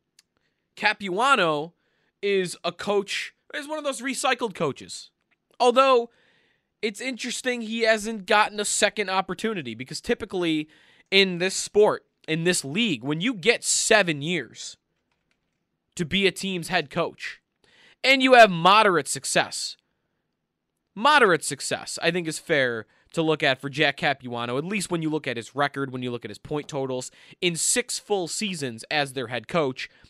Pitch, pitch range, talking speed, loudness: 180 Hz, 145-225 Hz, 155 wpm, -23 LUFS